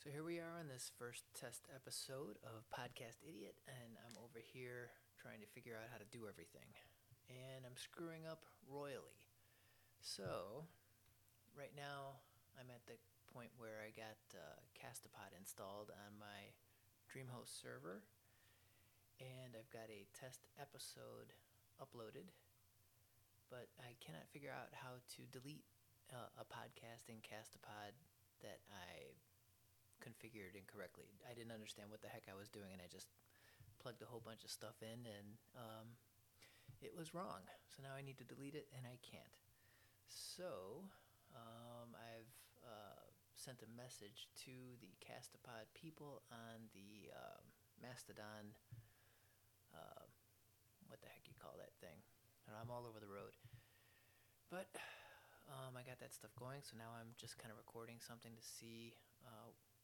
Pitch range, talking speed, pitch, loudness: 105-125 Hz, 150 wpm, 115 Hz, -58 LUFS